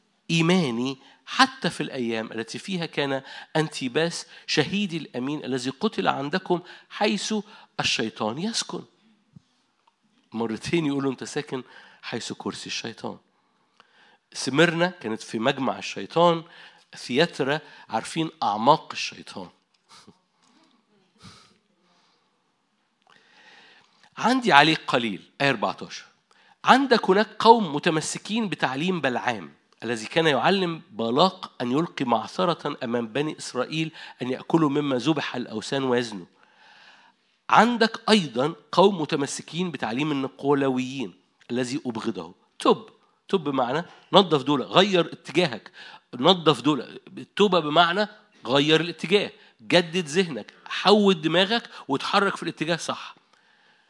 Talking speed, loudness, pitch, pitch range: 100 wpm, -24 LUFS, 160 Hz, 135-190 Hz